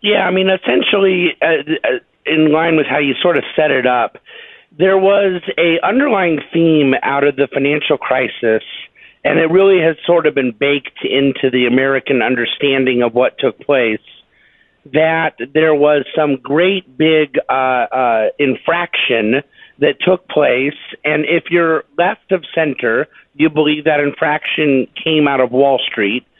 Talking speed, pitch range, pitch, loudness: 155 wpm, 140-175 Hz, 155 Hz, -14 LUFS